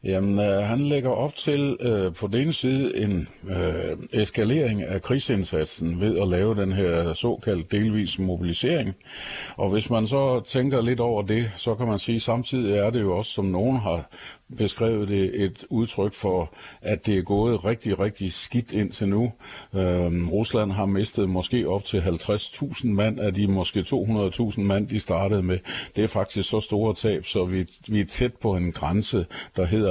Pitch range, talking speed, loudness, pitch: 95-115 Hz, 185 wpm, -24 LUFS, 105 Hz